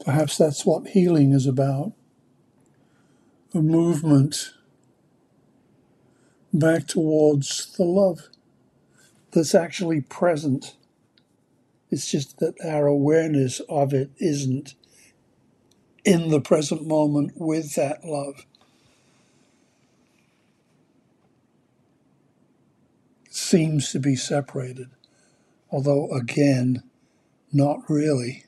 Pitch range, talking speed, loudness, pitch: 135-160 Hz, 80 wpm, -22 LUFS, 145 Hz